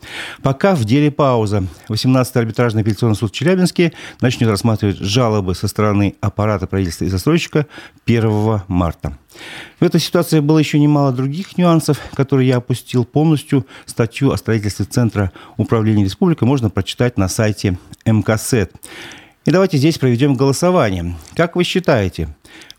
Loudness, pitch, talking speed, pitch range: -16 LUFS, 120 Hz, 135 wpm, 105-150 Hz